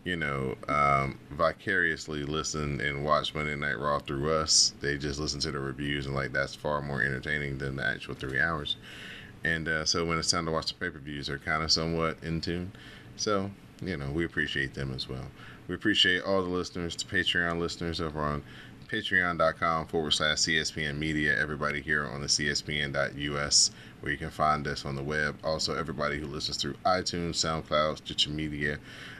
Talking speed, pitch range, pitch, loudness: 190 wpm, 70-80 Hz, 75 Hz, -29 LUFS